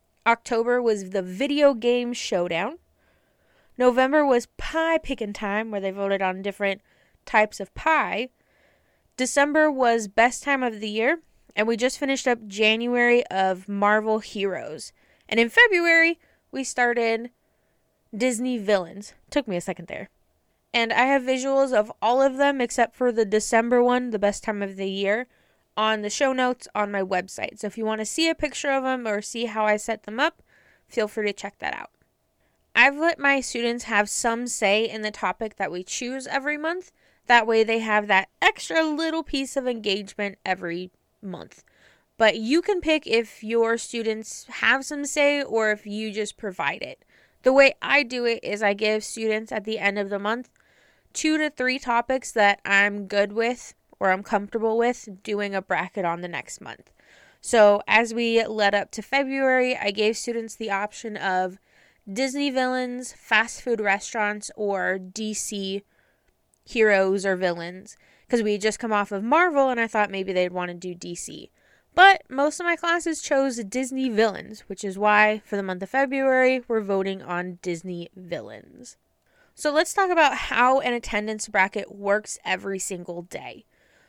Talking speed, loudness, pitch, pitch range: 175 wpm, -23 LUFS, 225 Hz, 205-255 Hz